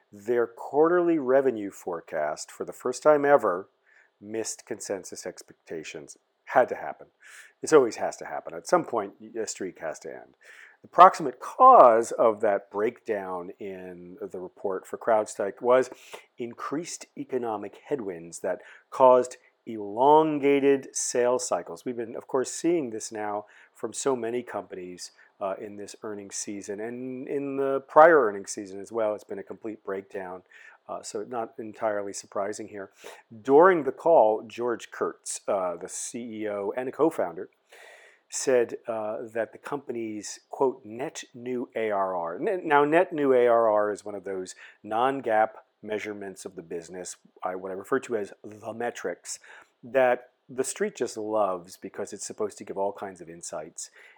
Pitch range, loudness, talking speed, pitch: 100-130 Hz, -26 LUFS, 155 wpm, 110 Hz